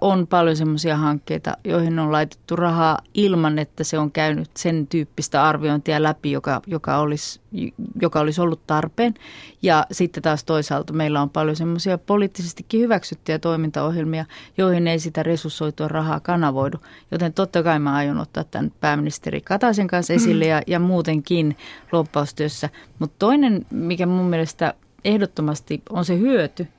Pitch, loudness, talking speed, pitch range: 160 Hz, -21 LUFS, 145 wpm, 150-175 Hz